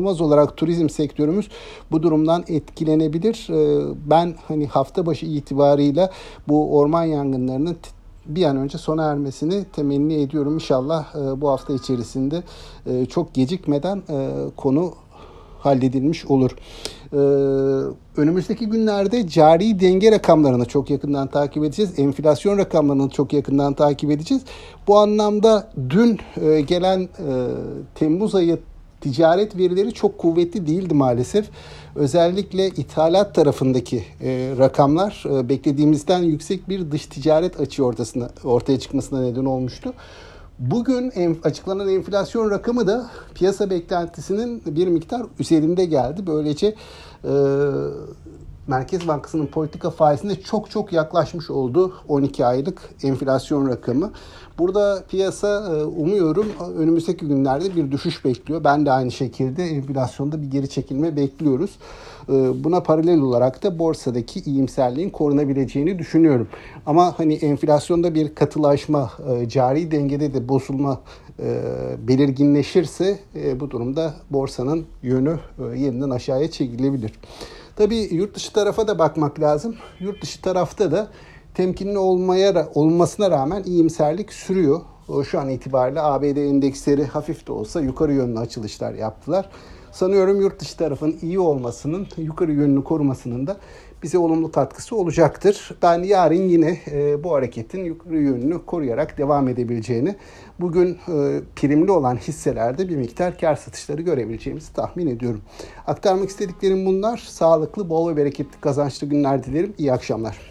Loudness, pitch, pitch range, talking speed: -20 LUFS, 155 Hz, 140-180 Hz, 120 wpm